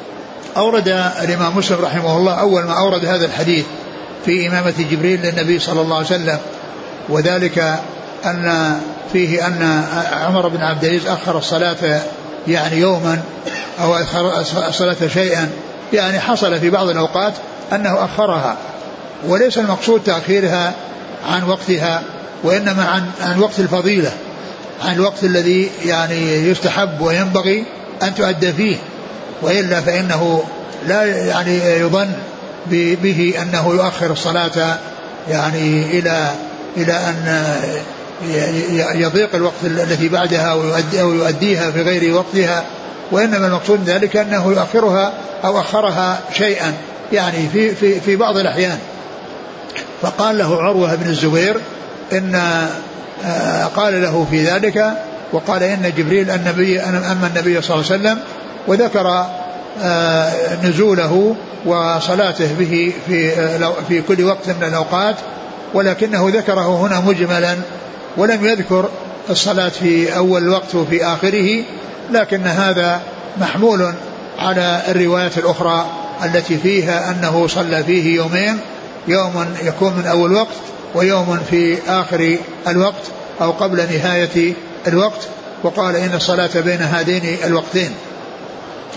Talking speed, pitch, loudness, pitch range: 115 wpm, 175 Hz, -15 LUFS, 170-190 Hz